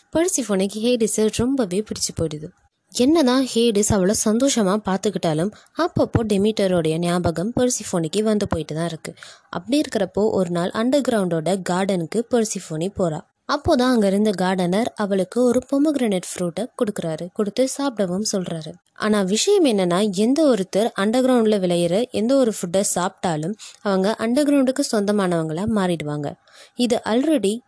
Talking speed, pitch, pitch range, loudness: 115 wpm, 210 Hz, 185-245 Hz, -20 LUFS